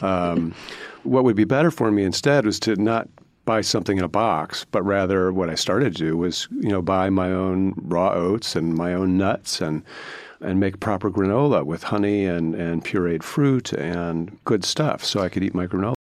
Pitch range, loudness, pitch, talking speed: 85-105 Hz, -22 LUFS, 95 Hz, 205 wpm